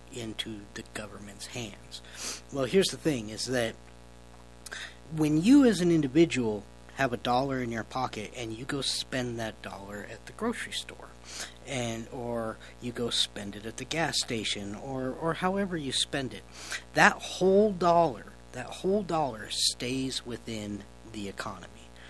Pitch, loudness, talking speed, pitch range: 120 Hz, -29 LUFS, 155 wpm, 100-140 Hz